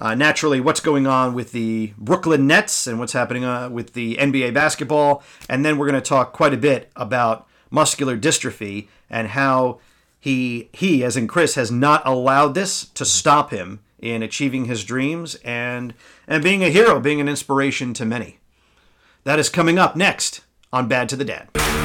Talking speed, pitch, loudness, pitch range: 185 wpm, 130 Hz, -19 LUFS, 120-150 Hz